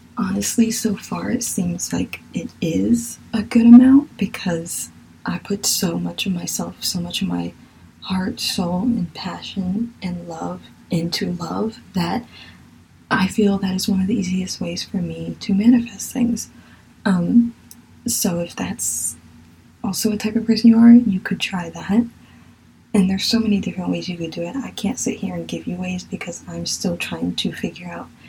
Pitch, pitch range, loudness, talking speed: 195 Hz, 170-225 Hz, -20 LUFS, 180 wpm